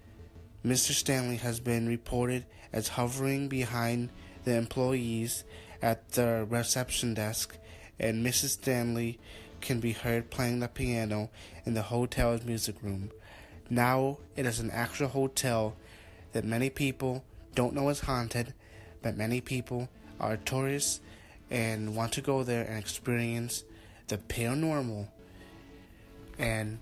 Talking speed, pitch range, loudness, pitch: 125 wpm, 110-125 Hz, -32 LUFS, 115 Hz